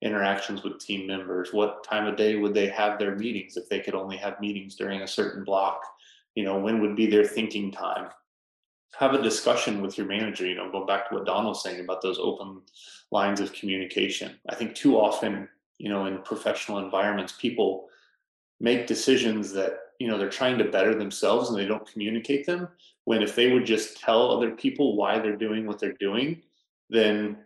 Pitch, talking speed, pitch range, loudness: 105 Hz, 200 wpm, 100-110 Hz, -27 LUFS